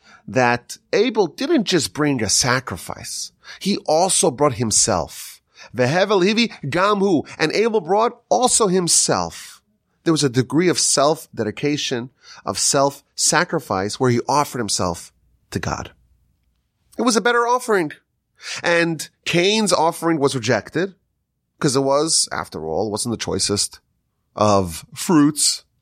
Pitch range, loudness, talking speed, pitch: 120-180 Hz, -19 LUFS, 130 wpm, 145 Hz